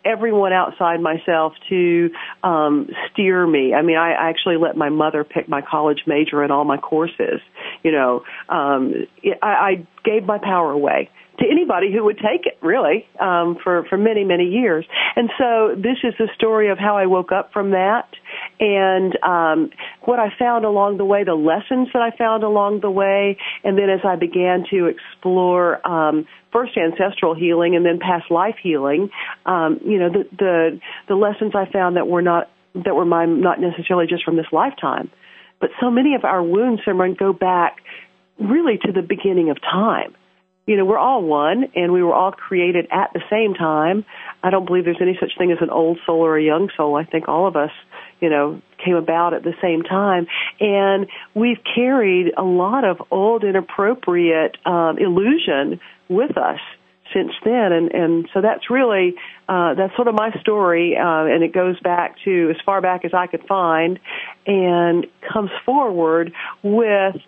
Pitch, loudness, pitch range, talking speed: 180 Hz, -18 LUFS, 165-205 Hz, 185 wpm